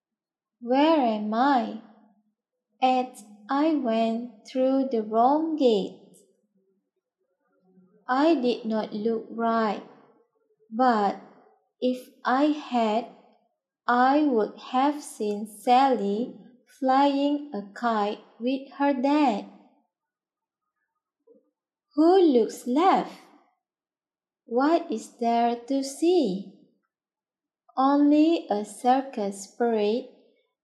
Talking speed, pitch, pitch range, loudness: 80 wpm, 245 Hz, 220-280 Hz, -25 LUFS